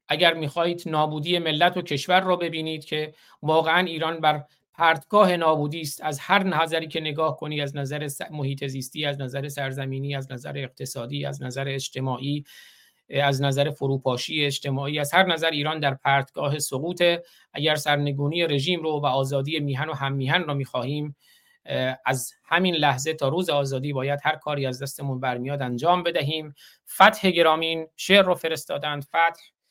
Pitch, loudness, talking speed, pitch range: 150 Hz, -24 LUFS, 155 wpm, 140-165 Hz